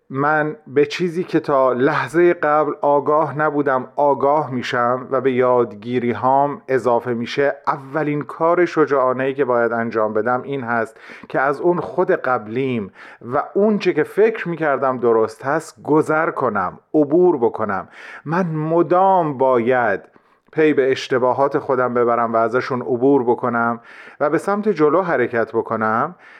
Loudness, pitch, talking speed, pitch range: -18 LUFS, 140 Hz, 140 wpm, 125-155 Hz